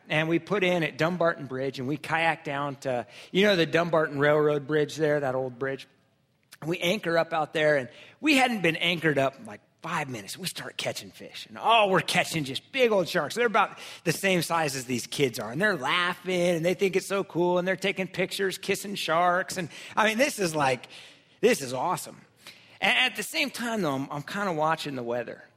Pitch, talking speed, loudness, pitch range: 165 Hz, 225 wpm, -26 LUFS, 145-190 Hz